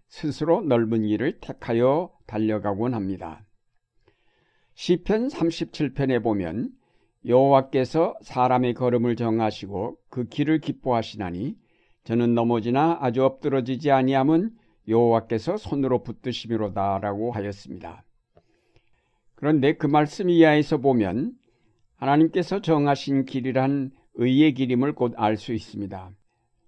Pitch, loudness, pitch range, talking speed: 125 Hz, -23 LUFS, 115-145 Hz, 270 characters per minute